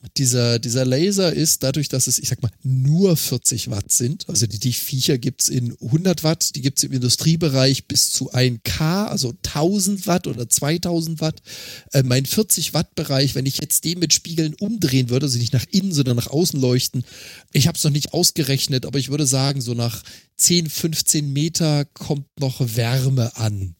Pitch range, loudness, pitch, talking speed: 125-160 Hz, -19 LUFS, 140 Hz, 195 wpm